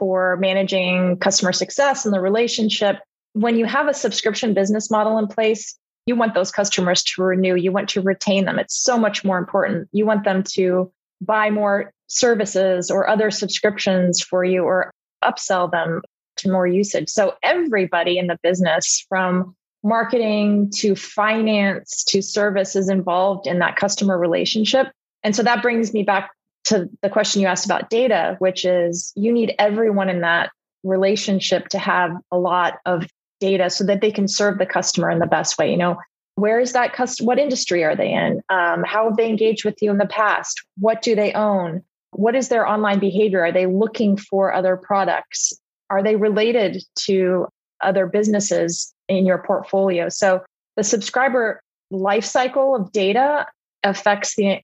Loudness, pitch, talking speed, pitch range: -19 LUFS, 200 Hz, 175 wpm, 185-215 Hz